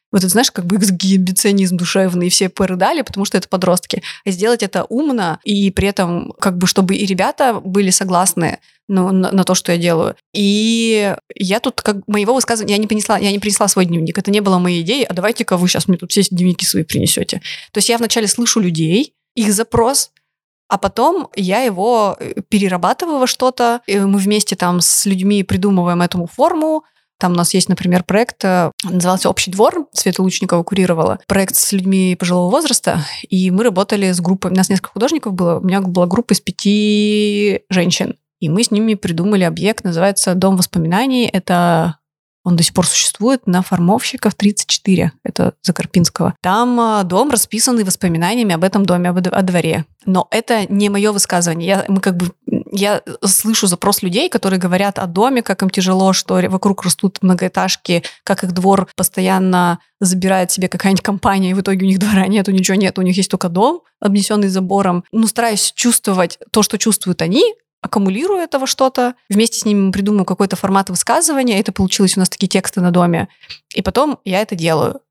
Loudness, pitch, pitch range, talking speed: -15 LUFS, 195 Hz, 185-215 Hz, 185 wpm